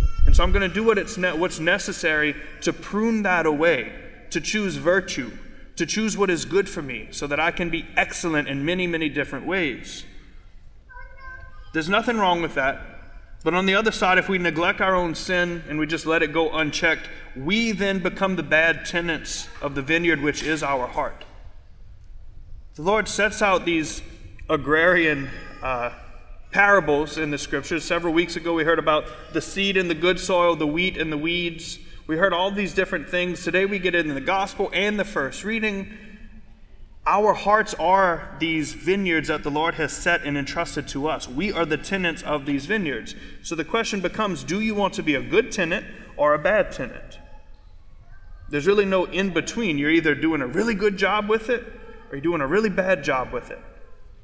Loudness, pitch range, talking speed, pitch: -22 LUFS, 150-195 Hz, 195 wpm, 170 Hz